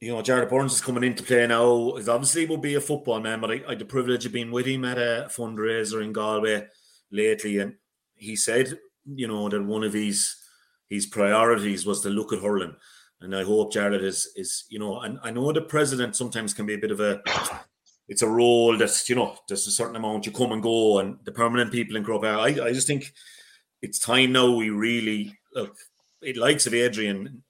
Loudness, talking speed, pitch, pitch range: -24 LUFS, 225 wpm, 115 Hz, 105-125 Hz